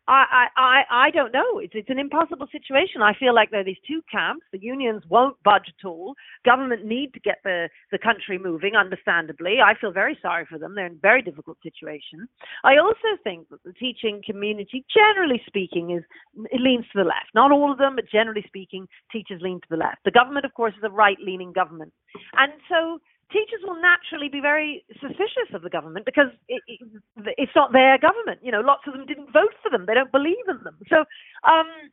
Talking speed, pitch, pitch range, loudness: 215 wpm, 235 Hz, 195-290 Hz, -21 LUFS